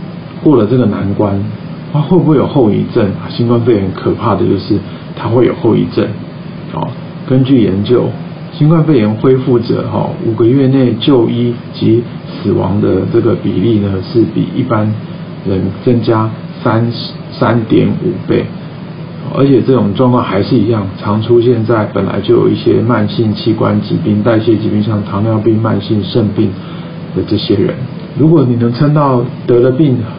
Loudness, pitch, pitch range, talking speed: -12 LUFS, 120 Hz, 110-145 Hz, 240 characters per minute